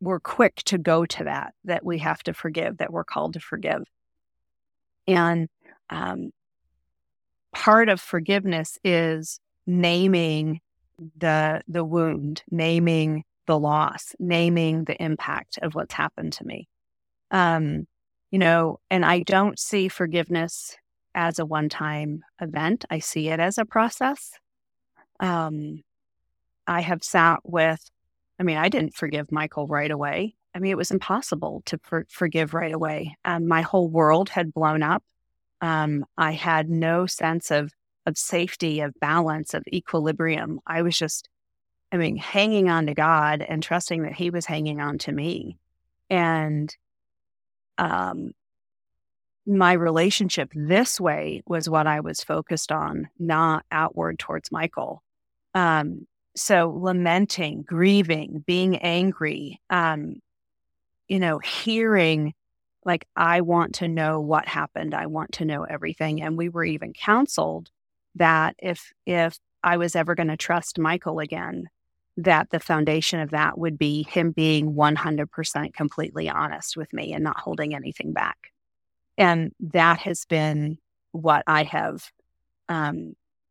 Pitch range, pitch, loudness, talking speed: 155-175 Hz, 165 Hz, -24 LUFS, 140 wpm